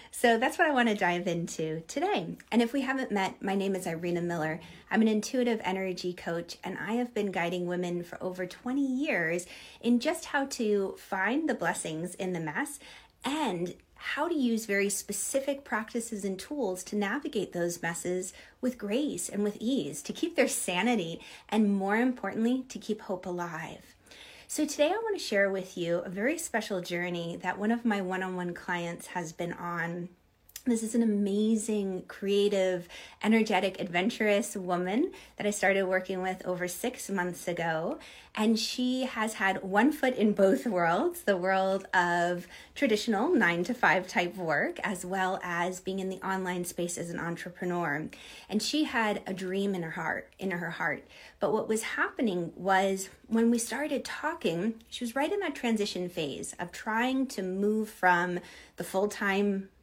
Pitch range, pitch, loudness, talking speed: 180-235 Hz, 195 Hz, -30 LUFS, 175 wpm